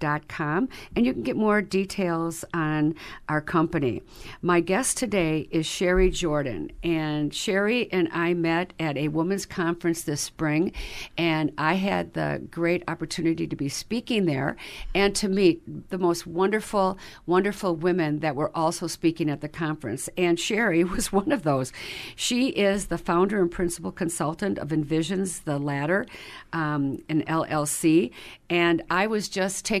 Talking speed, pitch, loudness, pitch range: 155 wpm, 170 Hz, -25 LUFS, 155-190 Hz